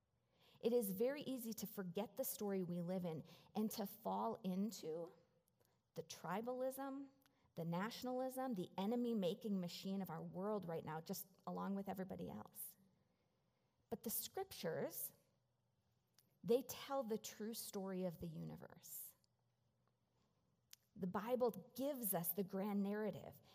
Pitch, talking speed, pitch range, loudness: 200 Hz, 130 wpm, 180-235 Hz, -46 LUFS